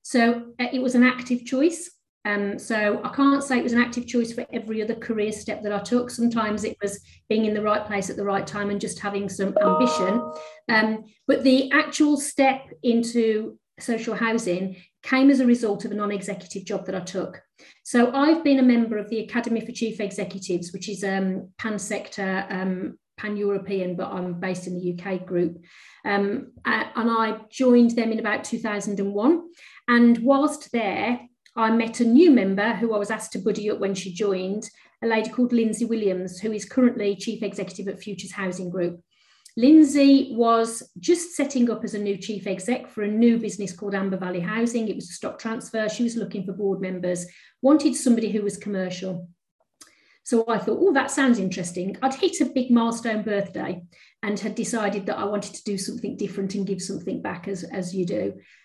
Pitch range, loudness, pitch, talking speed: 195-240 Hz, -24 LUFS, 215 Hz, 195 wpm